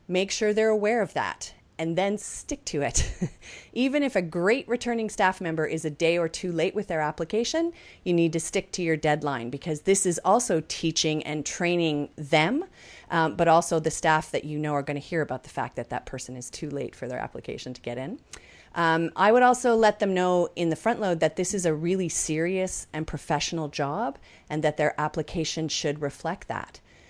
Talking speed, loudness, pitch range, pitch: 215 wpm, -26 LUFS, 155-190 Hz, 165 Hz